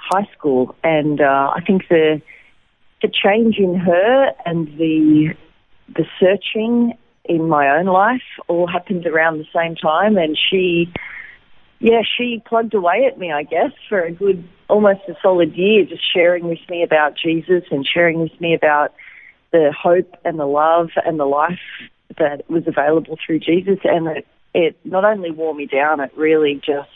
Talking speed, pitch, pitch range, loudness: 170 wpm, 170 Hz, 155-190 Hz, -16 LUFS